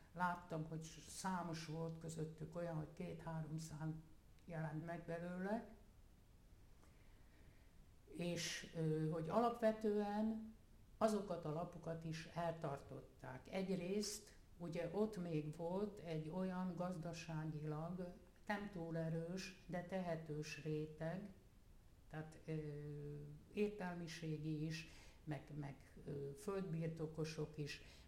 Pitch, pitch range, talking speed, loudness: 165 Hz, 155-180 Hz, 90 wpm, -47 LUFS